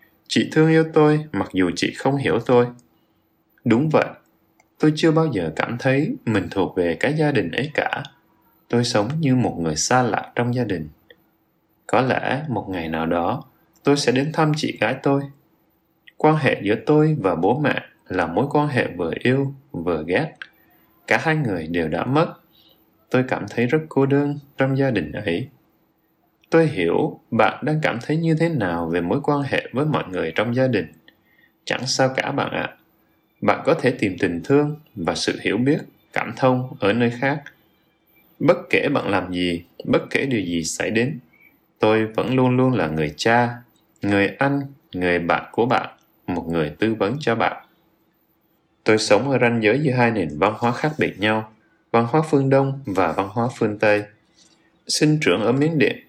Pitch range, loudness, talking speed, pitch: 110-150 Hz, -21 LUFS, 190 wpm, 130 Hz